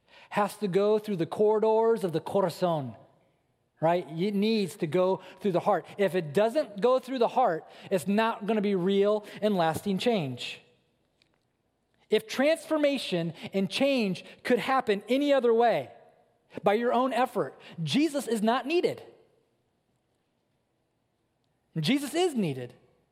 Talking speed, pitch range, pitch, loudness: 135 wpm, 170-245 Hz, 205 Hz, -27 LUFS